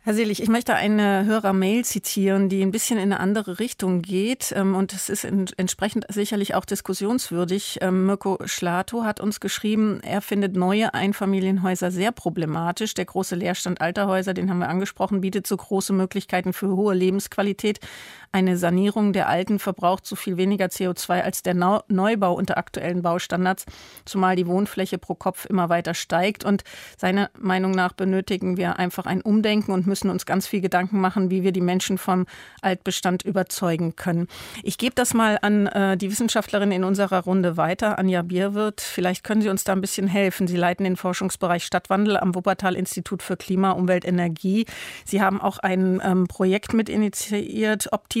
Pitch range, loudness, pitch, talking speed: 185-205 Hz, -23 LUFS, 190 Hz, 170 wpm